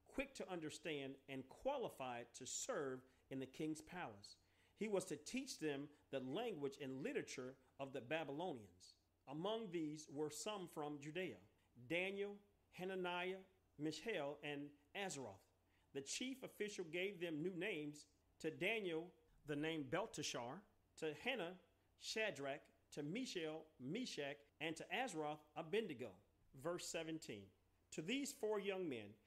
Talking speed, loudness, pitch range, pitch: 130 wpm, -48 LUFS, 135-180 Hz, 150 Hz